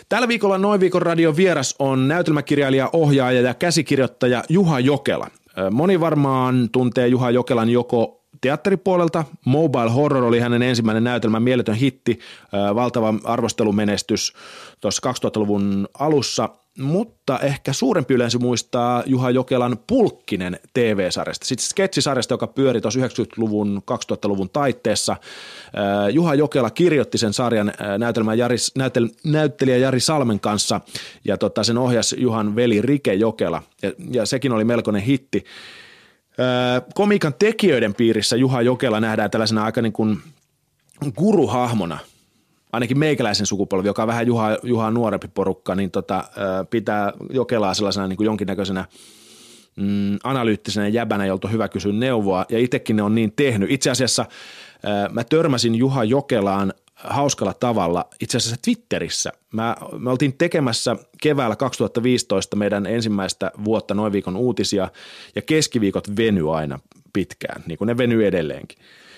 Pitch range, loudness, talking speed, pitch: 105-135 Hz, -20 LUFS, 130 wpm, 120 Hz